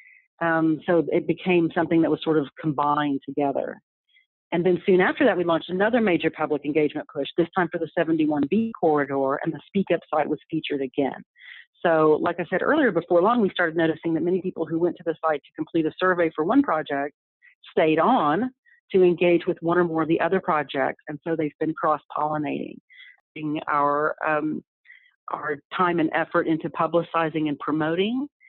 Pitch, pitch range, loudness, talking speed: 165 Hz, 155-180 Hz, -23 LUFS, 185 wpm